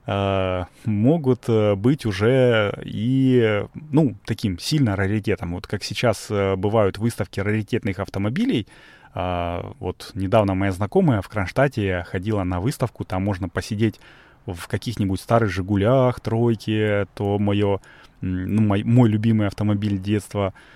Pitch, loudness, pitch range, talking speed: 105 Hz, -22 LUFS, 95-115 Hz, 115 wpm